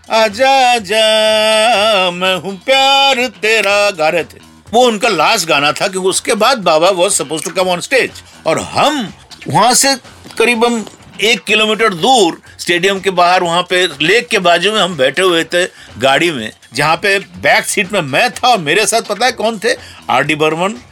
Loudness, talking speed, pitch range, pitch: -12 LUFS, 180 wpm, 175-225 Hz, 200 Hz